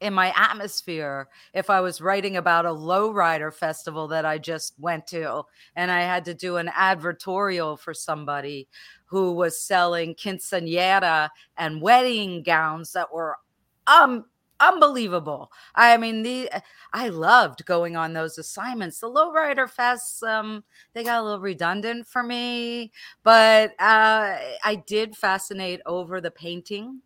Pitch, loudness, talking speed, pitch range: 185 Hz, -22 LUFS, 140 wpm, 170-220 Hz